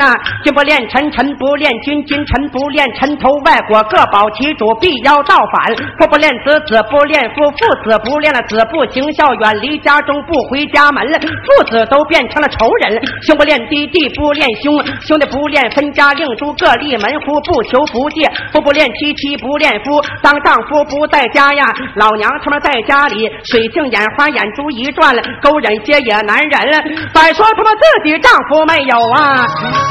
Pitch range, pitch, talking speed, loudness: 255-300 Hz, 290 Hz, 265 characters per minute, -10 LUFS